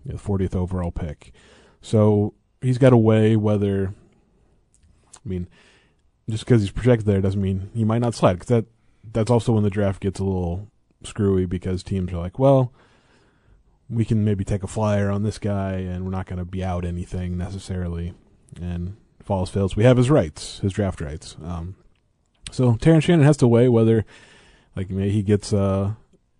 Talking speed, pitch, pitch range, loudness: 180 wpm, 100 Hz, 95-115 Hz, -21 LUFS